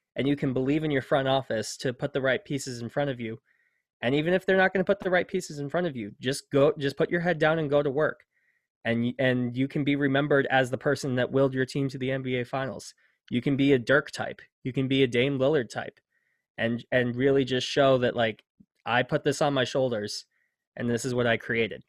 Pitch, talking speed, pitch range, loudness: 135 Hz, 250 wpm, 125-145 Hz, -27 LUFS